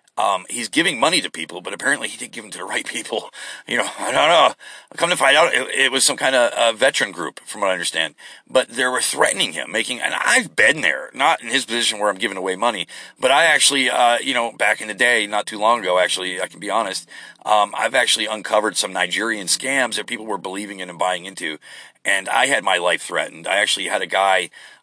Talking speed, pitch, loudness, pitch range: 245 wpm, 95 Hz, -18 LUFS, 90-105 Hz